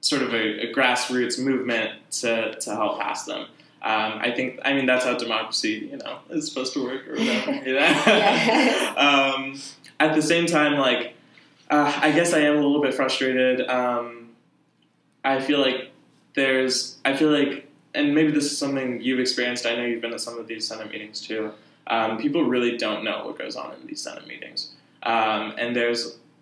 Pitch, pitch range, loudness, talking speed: 130 Hz, 120-145 Hz, -23 LUFS, 195 wpm